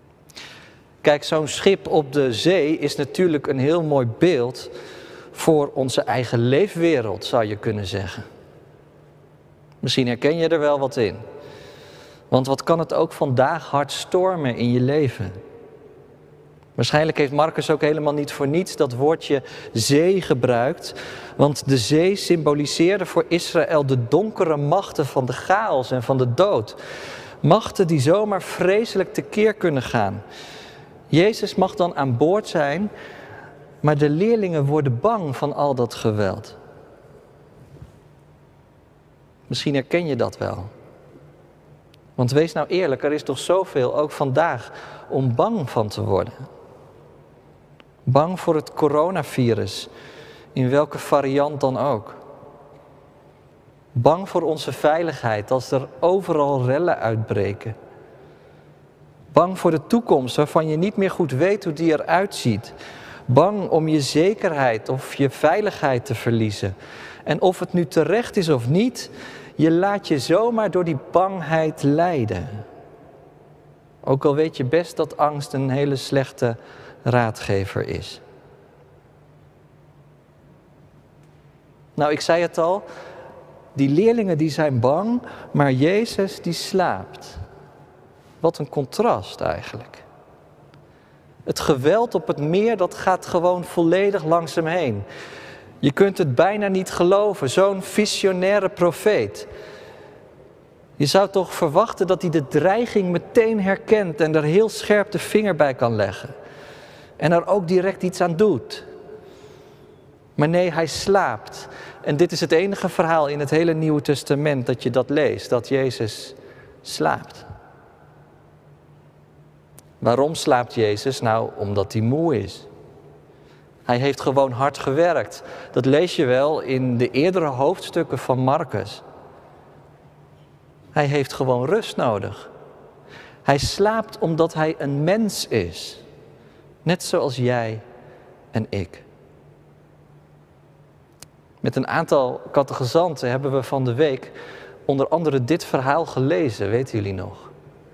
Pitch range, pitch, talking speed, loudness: 135-175 Hz, 150 Hz, 130 wpm, -21 LUFS